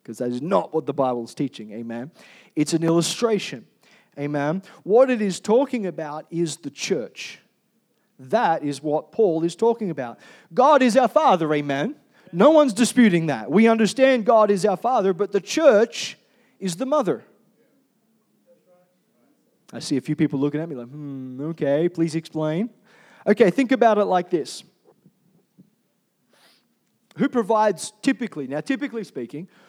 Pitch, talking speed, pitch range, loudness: 185 Hz, 150 wpm, 150-230 Hz, -21 LUFS